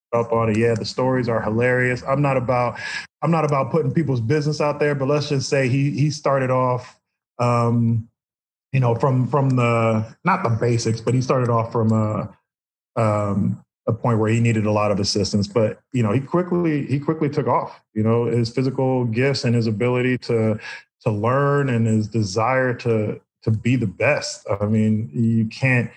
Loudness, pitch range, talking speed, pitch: -21 LUFS, 115-135 Hz, 195 wpm, 120 Hz